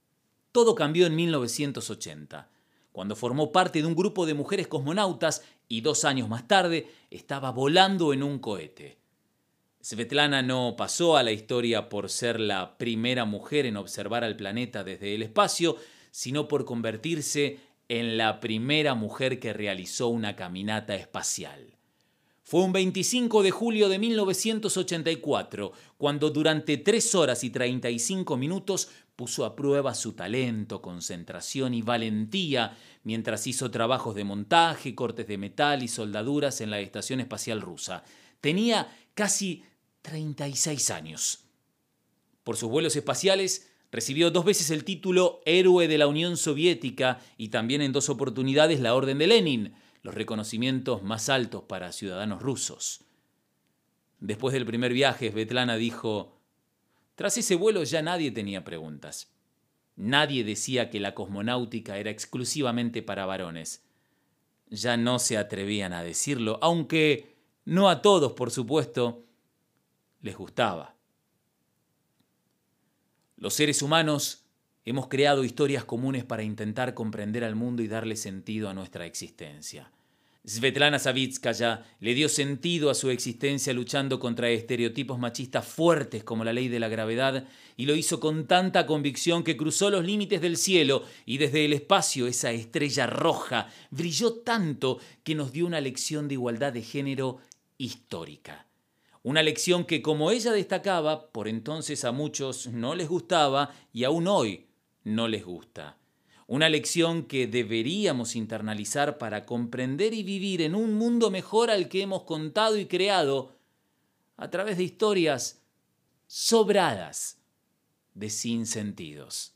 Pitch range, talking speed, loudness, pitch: 115-160 Hz, 140 wpm, -27 LUFS, 135 Hz